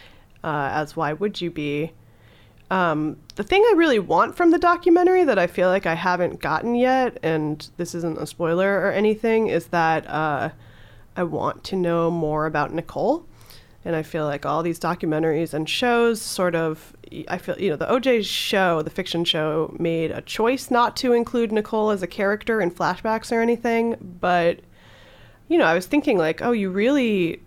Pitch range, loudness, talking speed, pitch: 160-225 Hz, -22 LUFS, 185 wpm, 175 Hz